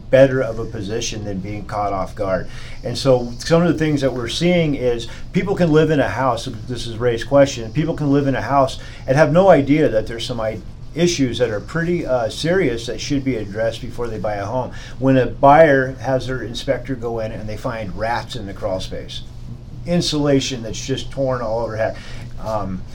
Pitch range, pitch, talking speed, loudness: 115-135 Hz, 125 Hz, 210 wpm, -19 LUFS